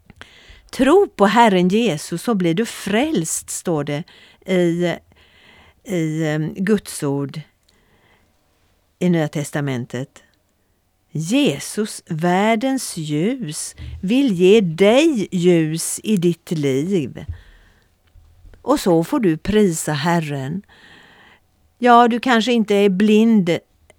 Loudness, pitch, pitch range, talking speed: -18 LUFS, 170 Hz, 140-215 Hz, 100 wpm